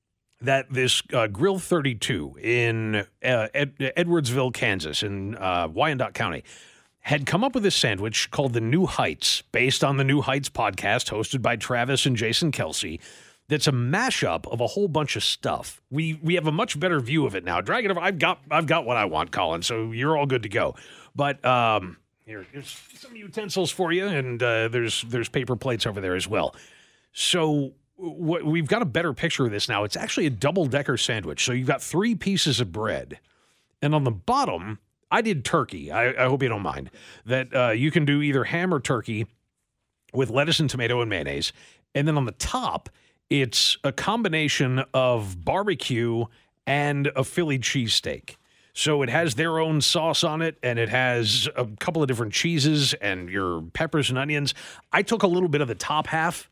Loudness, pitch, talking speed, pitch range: -24 LUFS, 135 Hz, 195 wpm, 115-155 Hz